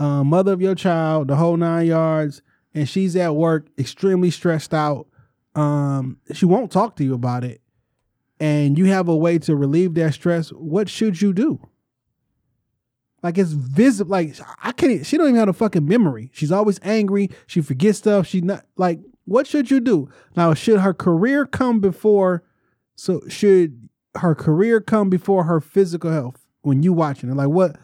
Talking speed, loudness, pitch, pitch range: 180 wpm, -19 LUFS, 170 Hz, 145-195 Hz